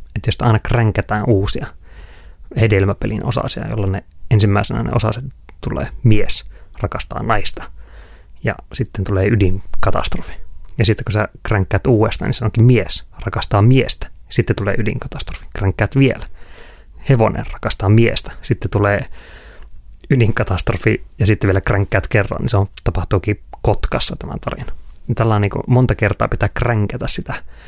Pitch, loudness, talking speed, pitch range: 110 Hz, -17 LUFS, 135 wpm, 100-120 Hz